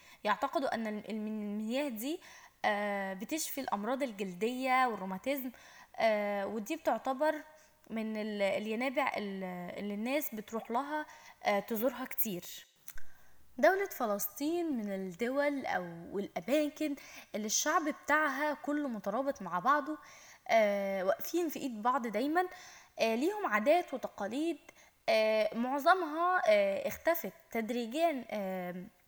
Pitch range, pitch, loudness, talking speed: 210-305 Hz, 260 Hz, -34 LUFS, 85 wpm